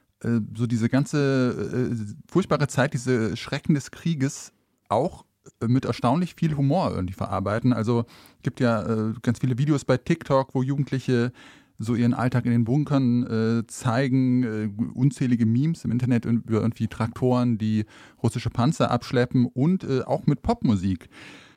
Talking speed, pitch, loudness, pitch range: 150 wpm, 125 Hz, -24 LUFS, 115-135 Hz